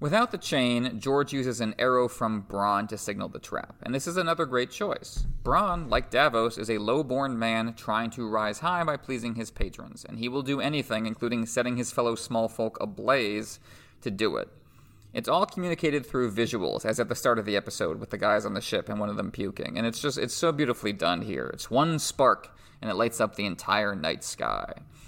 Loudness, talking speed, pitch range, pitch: -28 LUFS, 220 wpm, 110-140 Hz, 120 Hz